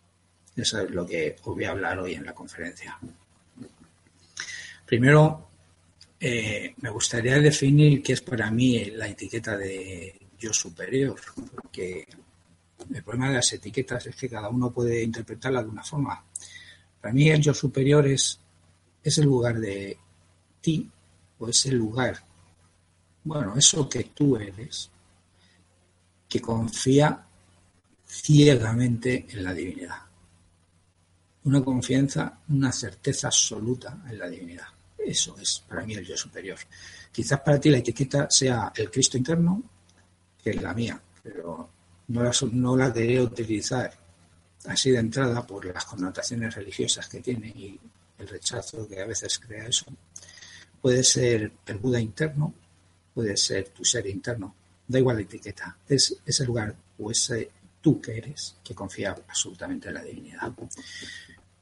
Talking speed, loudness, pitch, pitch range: 145 wpm, -25 LUFS, 115 Hz, 90-130 Hz